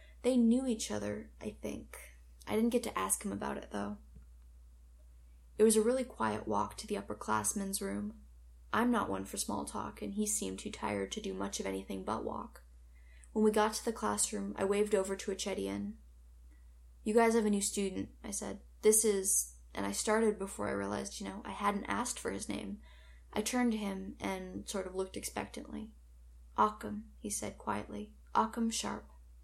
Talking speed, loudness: 190 wpm, -35 LUFS